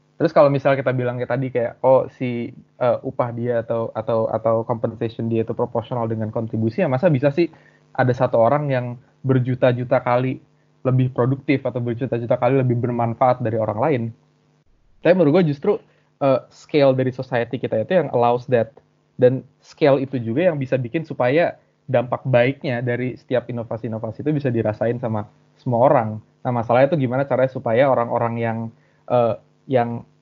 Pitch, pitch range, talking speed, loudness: 125 Hz, 115-135 Hz, 165 wpm, -20 LUFS